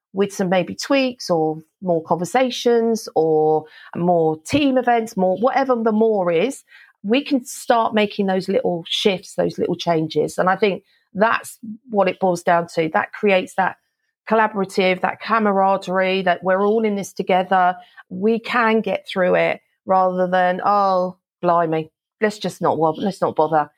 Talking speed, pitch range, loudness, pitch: 160 wpm, 180-225 Hz, -19 LUFS, 190 Hz